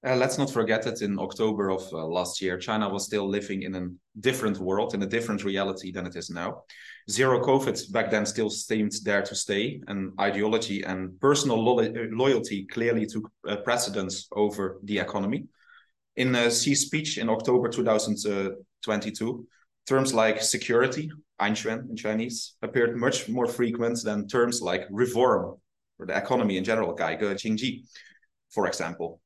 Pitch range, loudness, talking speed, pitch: 100-120 Hz, -27 LUFS, 160 wpm, 110 Hz